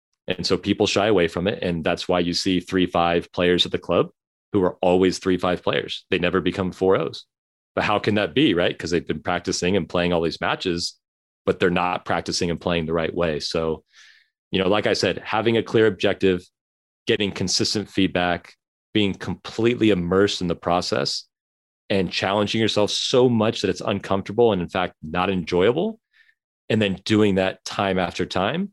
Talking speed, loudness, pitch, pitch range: 190 wpm, -22 LUFS, 95 Hz, 90-105 Hz